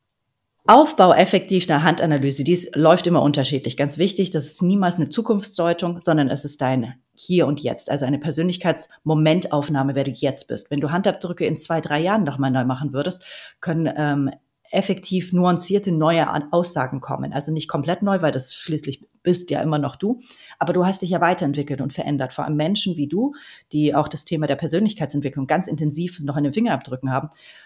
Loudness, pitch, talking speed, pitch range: -20 LUFS, 155 Hz, 185 wpm, 145-180 Hz